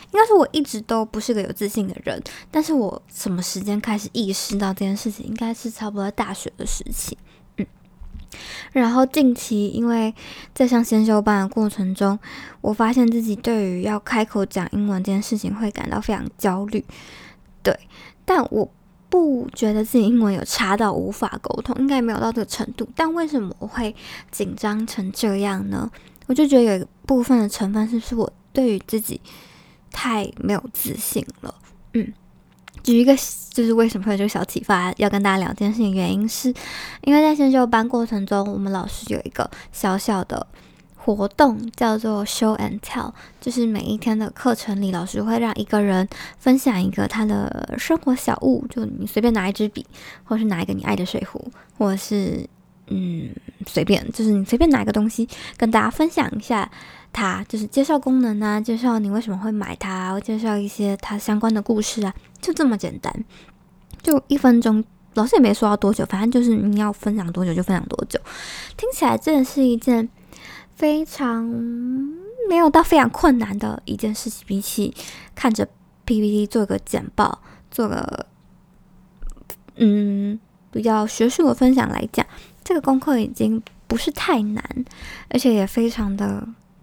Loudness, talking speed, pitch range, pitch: -21 LUFS, 275 characters per minute, 205-245 Hz, 220 Hz